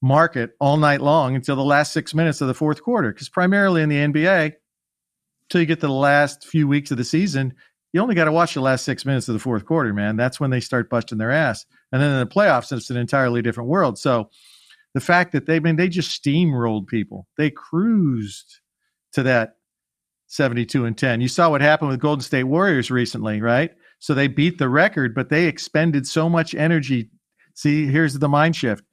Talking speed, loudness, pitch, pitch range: 215 wpm, -20 LUFS, 145 Hz, 130-160 Hz